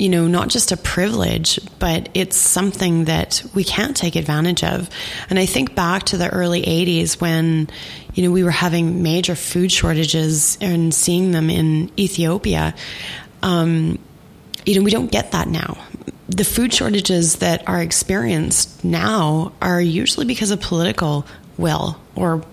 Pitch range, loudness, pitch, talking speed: 165-185 Hz, -17 LUFS, 175 Hz, 155 wpm